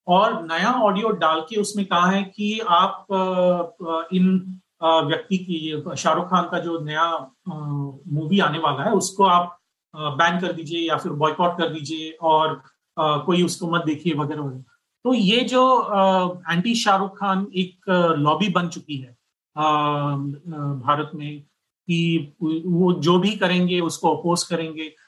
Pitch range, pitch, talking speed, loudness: 155-185 Hz, 170 Hz, 145 wpm, -21 LUFS